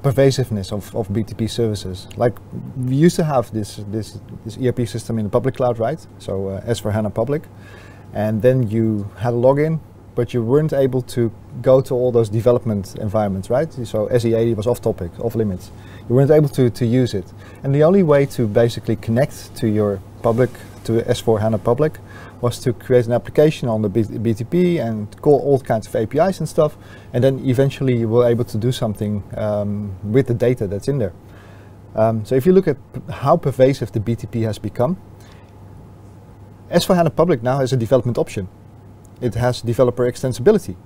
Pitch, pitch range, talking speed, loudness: 115 Hz, 105-130 Hz, 185 wpm, -19 LUFS